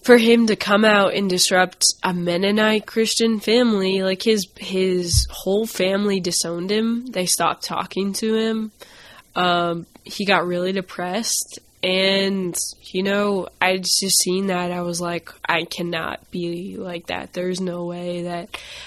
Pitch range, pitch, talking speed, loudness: 175-205 Hz, 185 Hz, 150 wpm, -20 LUFS